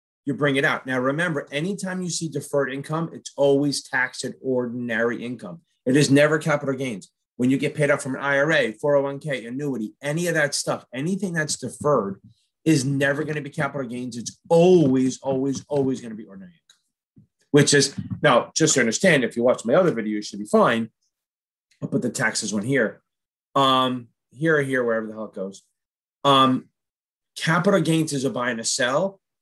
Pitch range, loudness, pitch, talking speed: 125-155 Hz, -22 LUFS, 140 Hz, 195 wpm